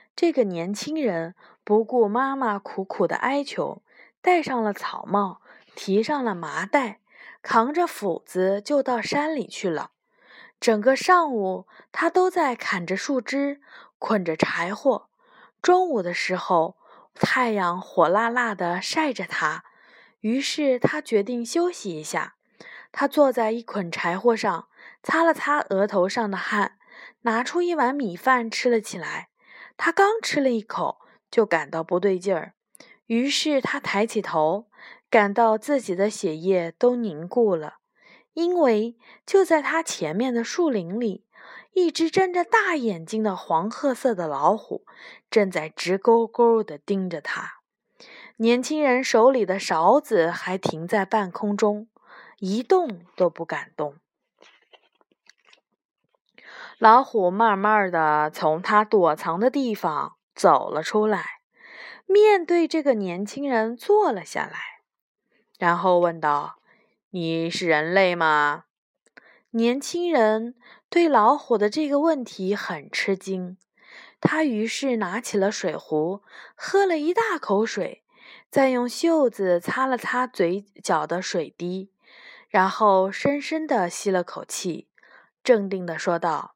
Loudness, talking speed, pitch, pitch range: -23 LUFS, 190 characters per minute, 225 Hz, 190-280 Hz